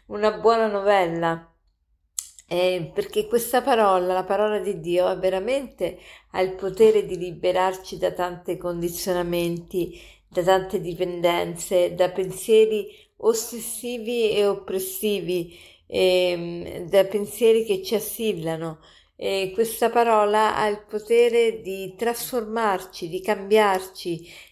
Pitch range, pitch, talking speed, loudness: 180-215 Hz, 190 Hz, 110 wpm, -23 LUFS